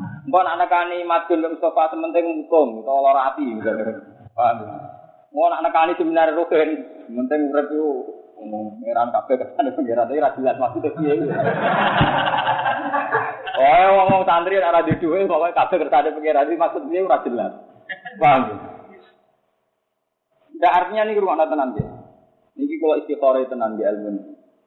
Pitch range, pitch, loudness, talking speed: 150-195 Hz, 165 Hz, -19 LUFS, 135 wpm